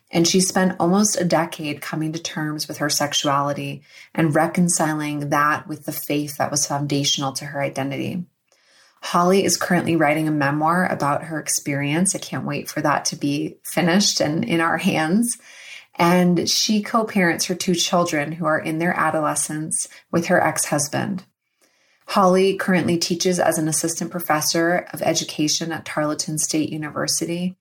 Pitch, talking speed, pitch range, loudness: 160 Hz, 160 wpm, 150-180 Hz, -20 LUFS